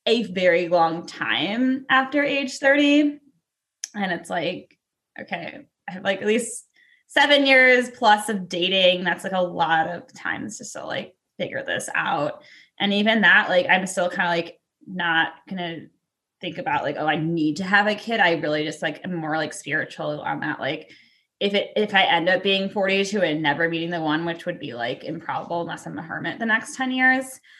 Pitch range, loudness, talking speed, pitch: 165-230 Hz, -21 LUFS, 200 wpm, 190 Hz